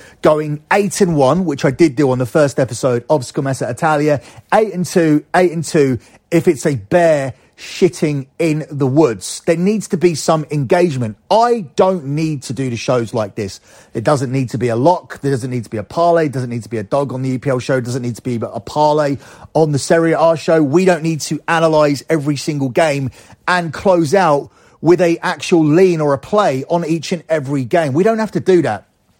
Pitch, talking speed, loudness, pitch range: 150 Hz, 225 wpm, -15 LUFS, 130-170 Hz